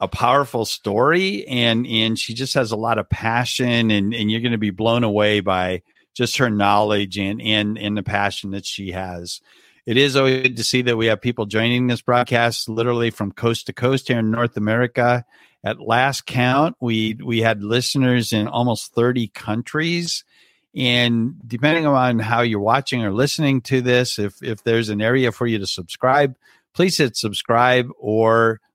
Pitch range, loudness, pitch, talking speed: 110-125 Hz, -19 LUFS, 115 Hz, 185 wpm